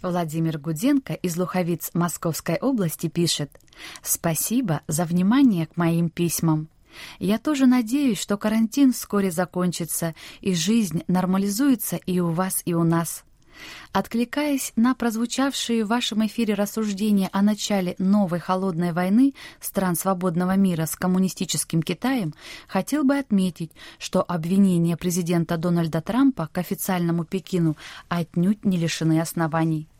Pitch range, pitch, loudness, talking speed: 170-215 Hz, 185 Hz, -23 LUFS, 125 wpm